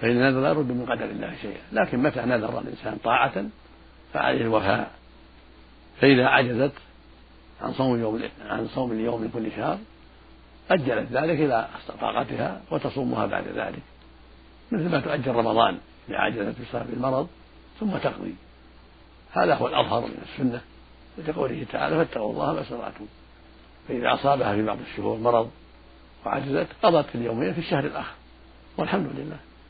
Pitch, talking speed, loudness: 100 Hz, 135 wpm, -25 LUFS